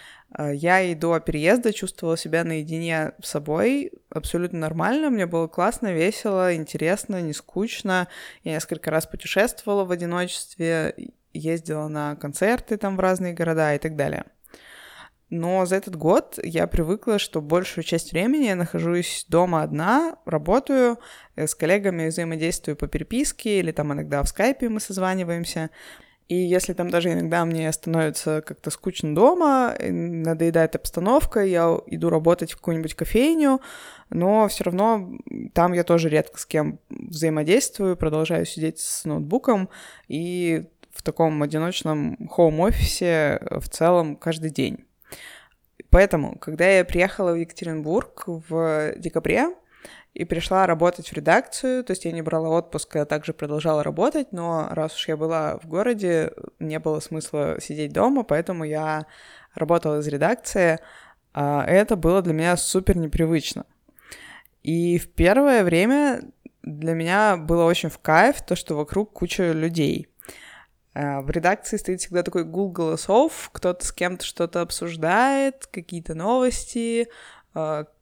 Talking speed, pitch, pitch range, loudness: 135 wpm, 170 Hz, 160-195 Hz, -23 LUFS